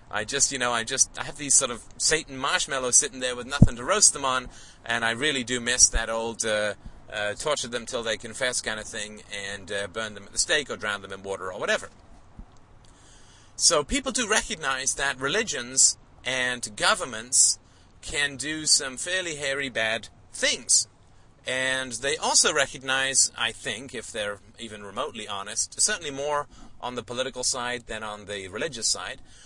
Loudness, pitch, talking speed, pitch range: -24 LUFS, 120 Hz, 180 wpm, 105-135 Hz